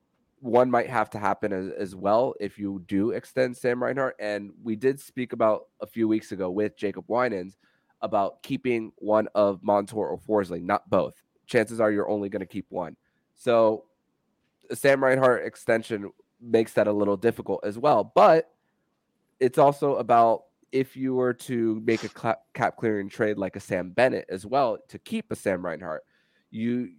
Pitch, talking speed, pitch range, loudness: 110 Hz, 175 wpm, 105-125 Hz, -26 LUFS